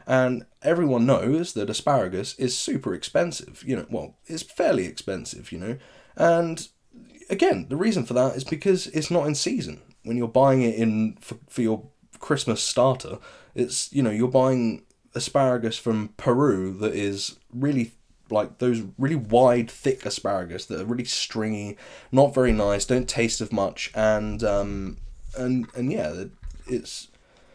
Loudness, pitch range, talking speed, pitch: -24 LUFS, 110-130 Hz, 155 wpm, 120 Hz